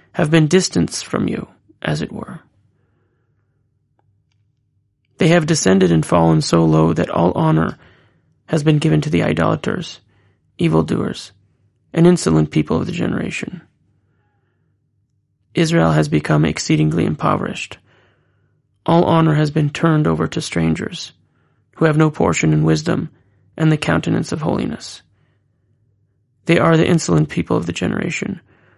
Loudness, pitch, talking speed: -17 LUFS, 110 Hz, 130 wpm